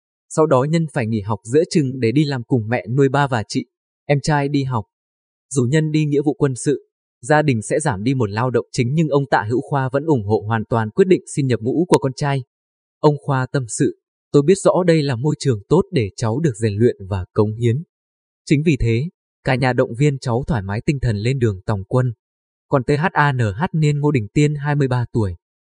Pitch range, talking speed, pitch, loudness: 115-150 Hz, 230 wpm, 130 Hz, -19 LUFS